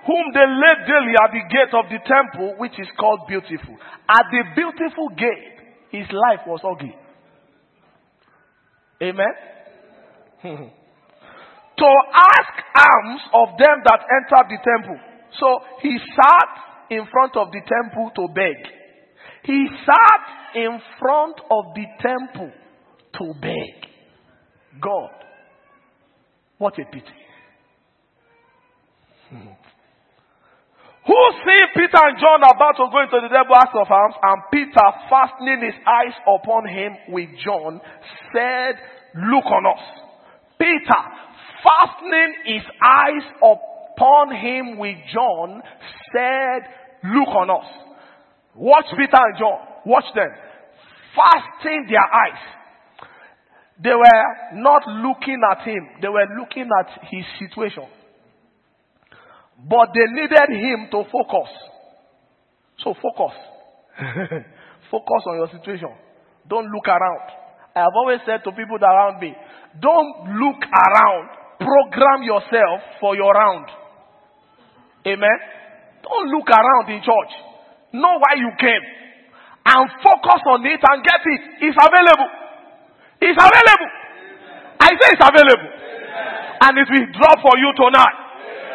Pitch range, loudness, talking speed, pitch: 215-295 Hz, -15 LUFS, 120 wpm, 250 Hz